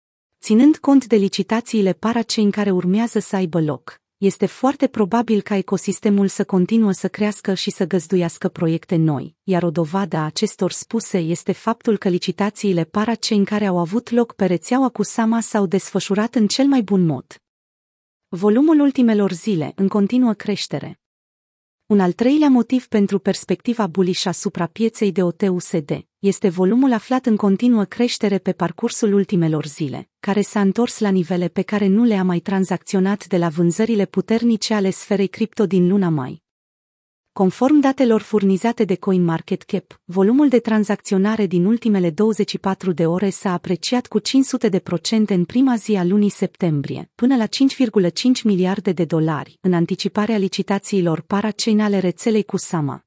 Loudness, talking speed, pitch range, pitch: -19 LUFS, 160 wpm, 185-220 Hz, 200 Hz